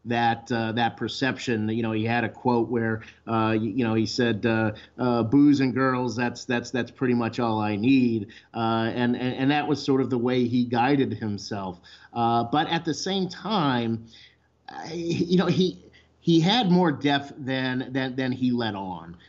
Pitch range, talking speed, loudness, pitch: 115-135 Hz, 195 wpm, -25 LUFS, 120 Hz